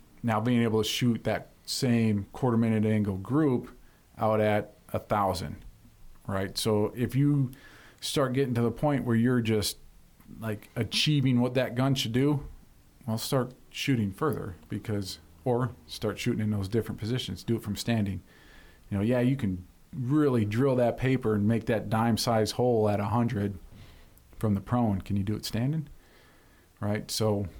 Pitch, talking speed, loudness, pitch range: 110 Hz, 170 wpm, -28 LUFS, 105-125 Hz